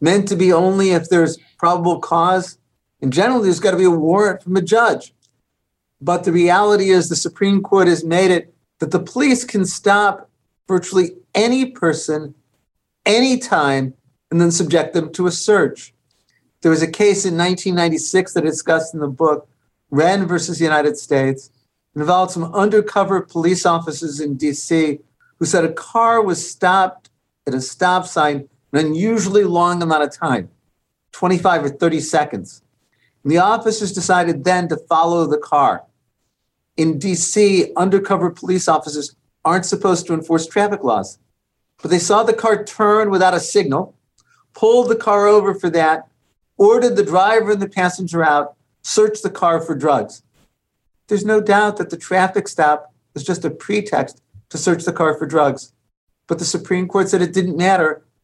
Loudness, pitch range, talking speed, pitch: -16 LUFS, 155-195 Hz, 165 wpm, 175 Hz